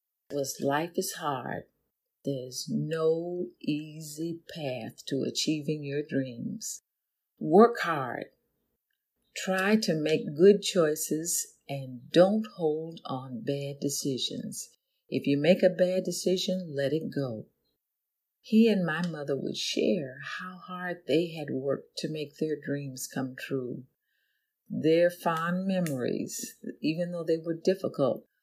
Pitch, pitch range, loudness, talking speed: 160 Hz, 140-180 Hz, -29 LUFS, 125 wpm